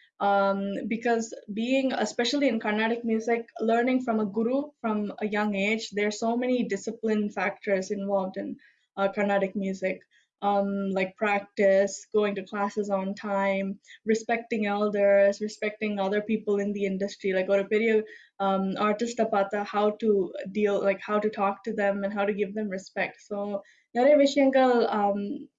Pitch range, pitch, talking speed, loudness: 200-225 Hz, 205 Hz, 150 wpm, -27 LUFS